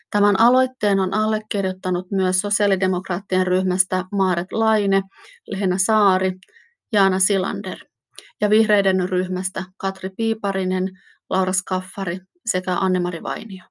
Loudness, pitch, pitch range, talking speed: -21 LUFS, 190 Hz, 185-205 Hz, 100 wpm